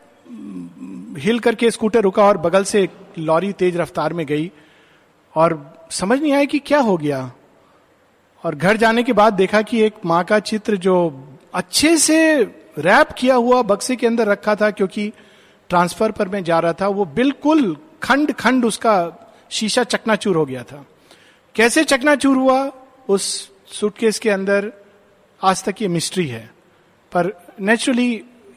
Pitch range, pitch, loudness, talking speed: 175-235 Hz, 205 Hz, -17 LUFS, 155 wpm